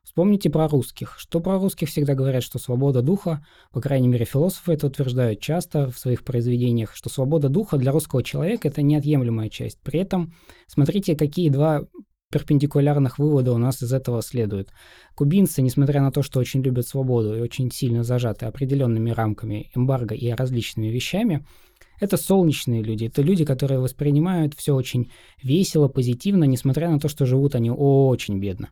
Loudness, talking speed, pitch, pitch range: -22 LUFS, 165 wpm, 135 Hz, 120-155 Hz